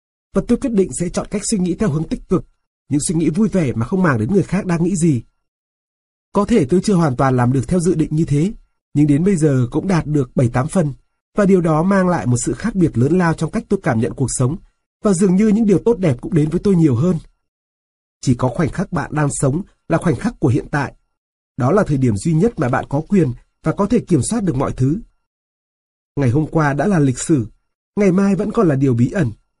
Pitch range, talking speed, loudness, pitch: 135-190 Hz, 255 wpm, -17 LUFS, 160 Hz